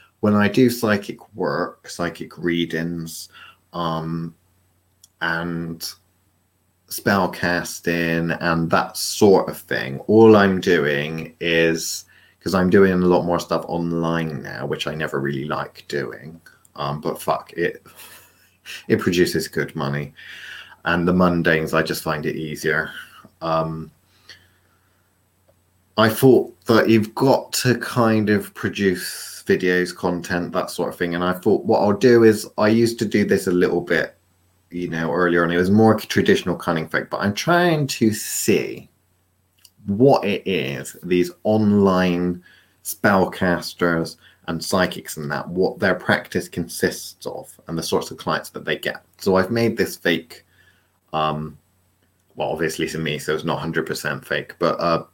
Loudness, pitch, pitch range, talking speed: -20 LUFS, 90 Hz, 85-100 Hz, 150 wpm